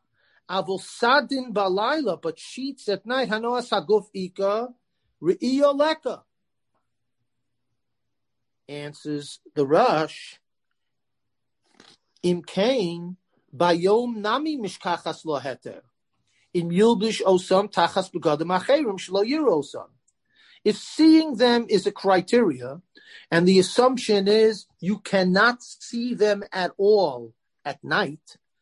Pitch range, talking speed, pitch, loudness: 170-235 Hz, 90 wpm, 195 Hz, -23 LUFS